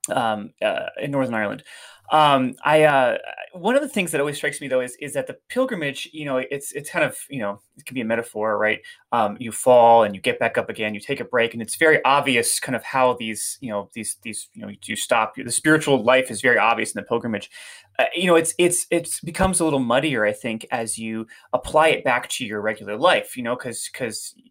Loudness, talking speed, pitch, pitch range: -21 LUFS, 240 wpm, 130 Hz, 110-165 Hz